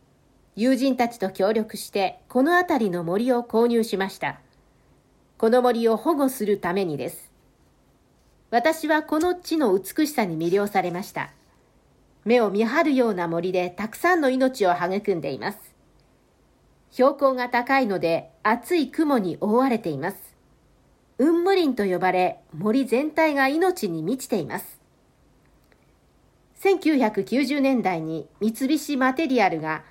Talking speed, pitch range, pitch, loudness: 265 characters per minute, 195-280 Hz, 240 Hz, -23 LUFS